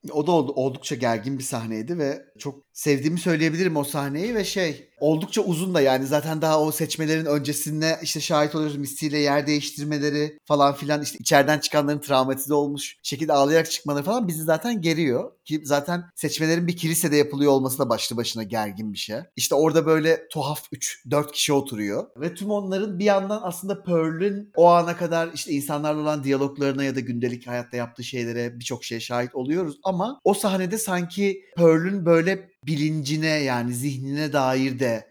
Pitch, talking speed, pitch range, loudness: 150 Hz, 165 wpm, 140-165 Hz, -23 LUFS